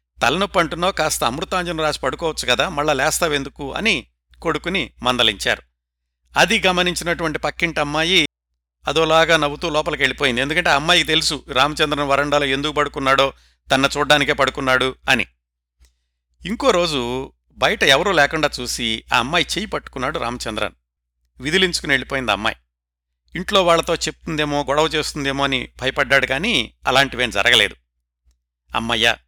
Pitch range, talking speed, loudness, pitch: 100-155 Hz, 115 wpm, -18 LUFS, 140 Hz